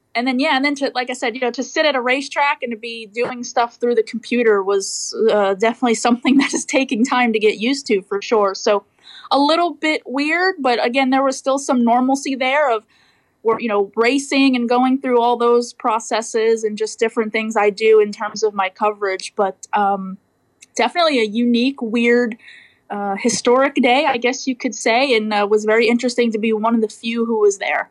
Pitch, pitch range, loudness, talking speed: 240 Hz, 220-265 Hz, -17 LUFS, 215 wpm